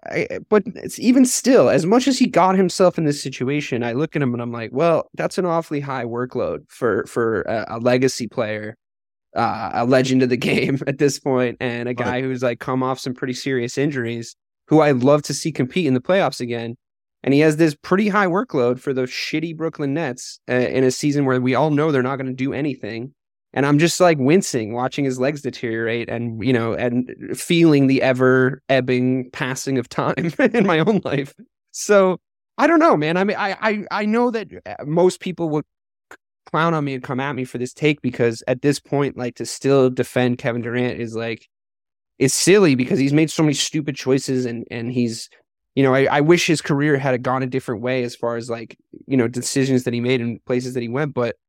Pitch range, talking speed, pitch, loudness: 125-155 Hz, 220 wpm, 130 Hz, -19 LUFS